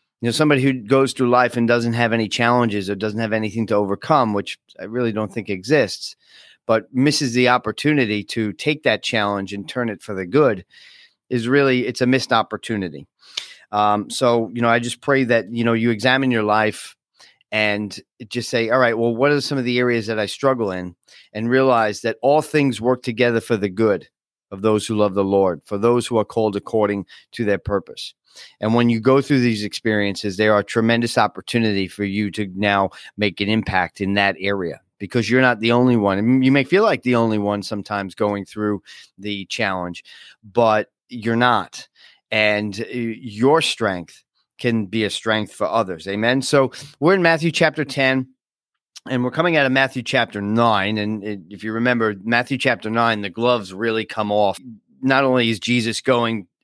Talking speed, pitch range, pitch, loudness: 195 wpm, 105-125 Hz, 115 Hz, -19 LUFS